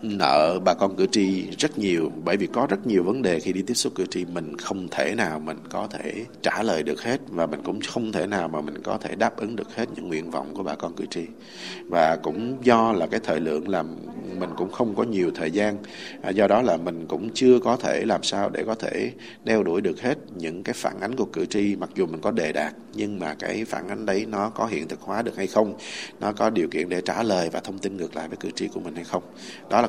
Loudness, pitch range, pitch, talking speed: -25 LUFS, 80-110 Hz, 95 Hz, 265 wpm